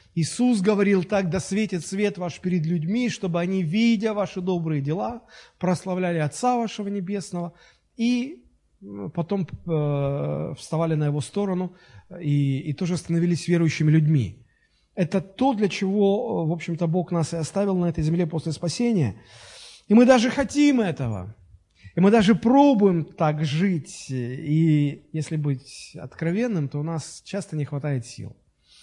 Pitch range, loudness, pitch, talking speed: 150-200 Hz, -23 LUFS, 175 Hz, 140 wpm